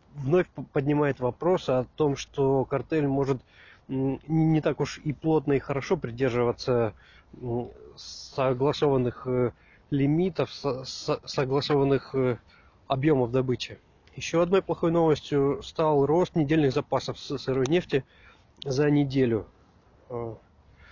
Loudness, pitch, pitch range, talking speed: -27 LUFS, 135 Hz, 125-150 Hz, 95 wpm